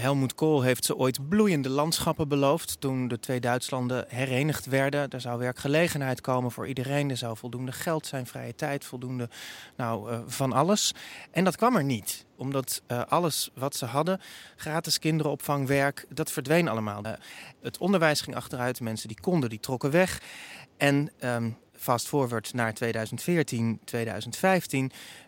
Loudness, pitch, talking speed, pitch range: -28 LUFS, 135 Hz, 160 wpm, 120-150 Hz